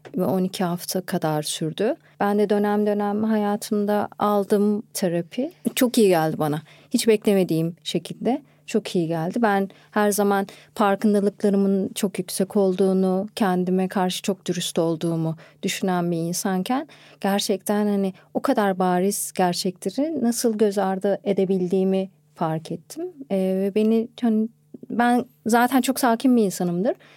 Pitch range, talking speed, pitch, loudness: 180-215 Hz, 125 wpm, 195 Hz, -23 LUFS